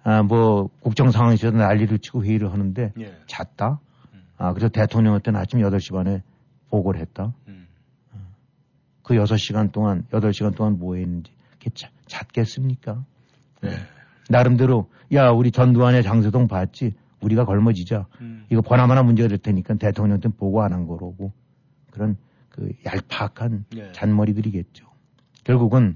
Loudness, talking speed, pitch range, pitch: -20 LUFS, 285 characters per minute, 100-125 Hz, 110 Hz